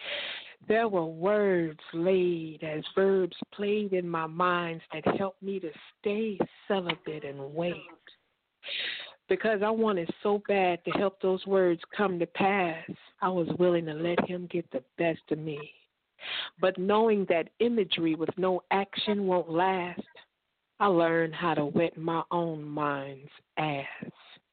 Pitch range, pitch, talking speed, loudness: 165-195 Hz, 180 Hz, 145 wpm, -29 LUFS